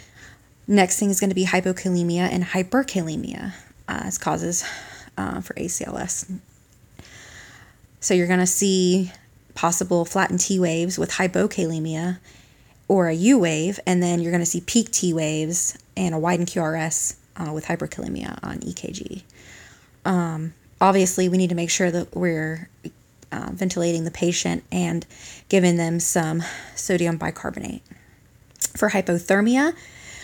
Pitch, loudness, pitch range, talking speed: 175 Hz, -22 LUFS, 160-185 Hz, 135 wpm